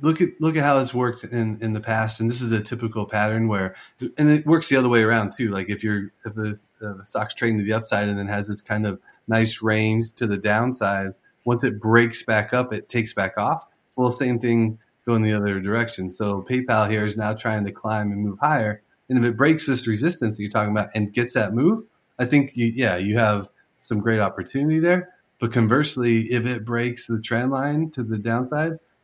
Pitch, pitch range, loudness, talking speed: 115 Hz, 105-125 Hz, -22 LUFS, 225 wpm